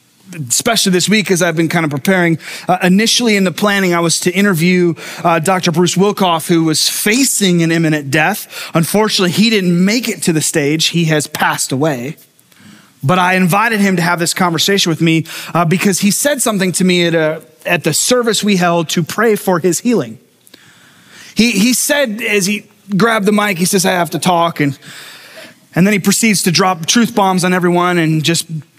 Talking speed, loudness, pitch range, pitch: 200 wpm, -13 LUFS, 165-205 Hz, 180 Hz